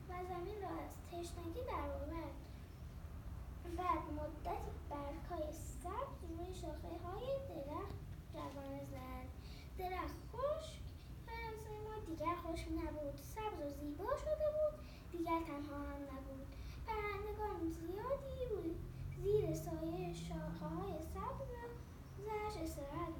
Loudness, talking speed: -45 LUFS, 110 wpm